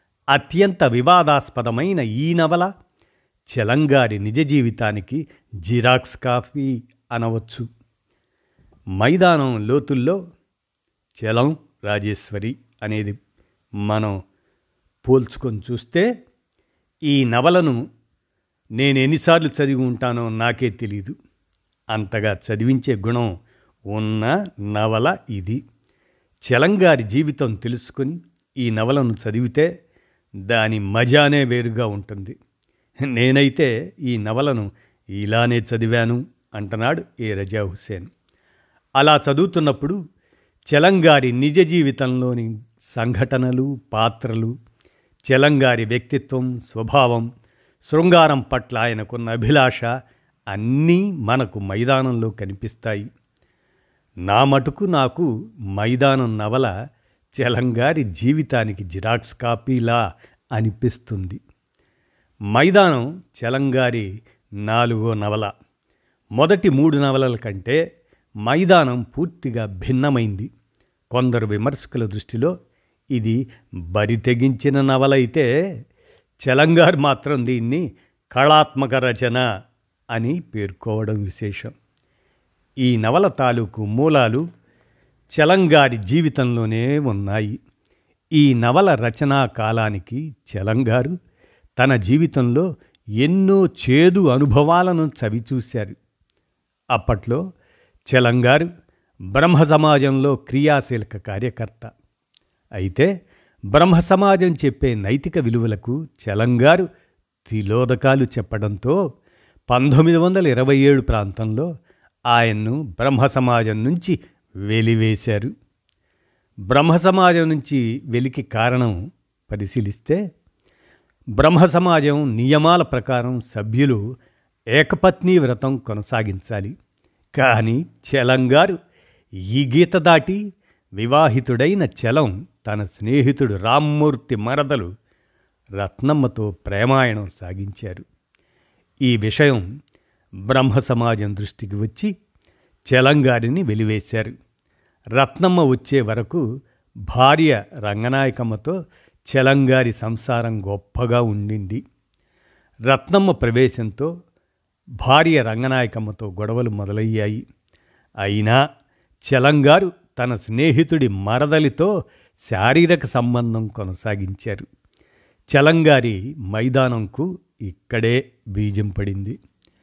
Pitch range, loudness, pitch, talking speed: 110-140 Hz, -18 LUFS, 125 Hz, 75 wpm